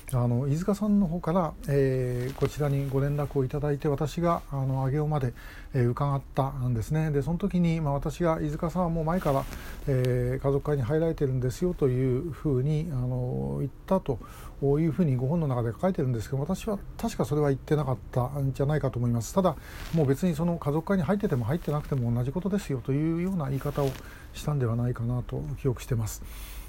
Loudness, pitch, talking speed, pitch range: -28 LUFS, 140 Hz, 410 characters per minute, 130-160 Hz